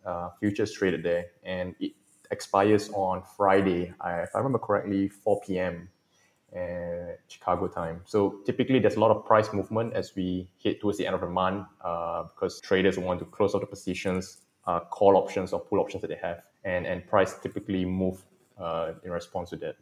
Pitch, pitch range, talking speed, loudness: 95 Hz, 90-100 Hz, 190 wpm, -28 LUFS